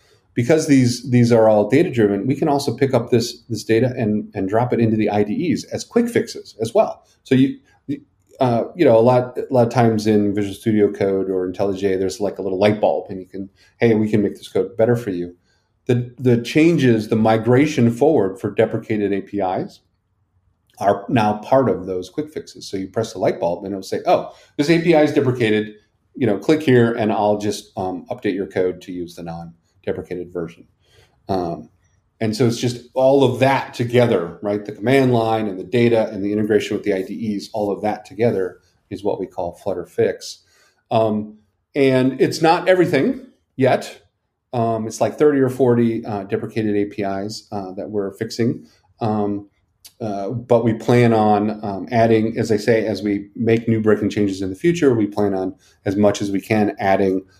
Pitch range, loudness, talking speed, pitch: 100-120 Hz, -19 LUFS, 200 wpm, 110 Hz